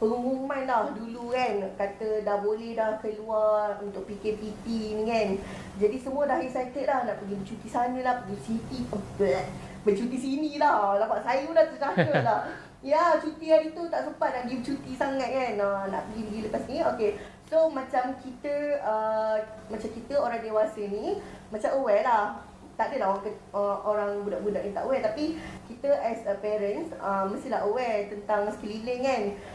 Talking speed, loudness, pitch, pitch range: 175 wpm, -28 LUFS, 225 Hz, 210-270 Hz